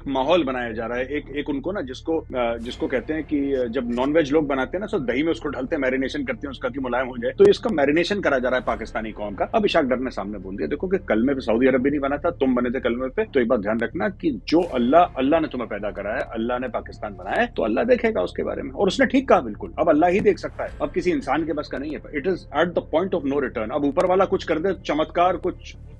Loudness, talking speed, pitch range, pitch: -23 LUFS, 285 wpm, 125-175 Hz, 140 Hz